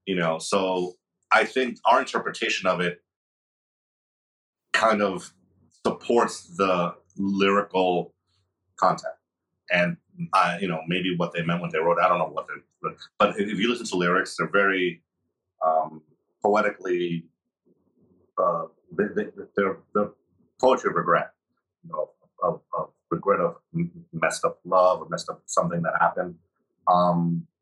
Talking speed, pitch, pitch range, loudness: 140 wpm, 90 Hz, 85-100 Hz, -25 LUFS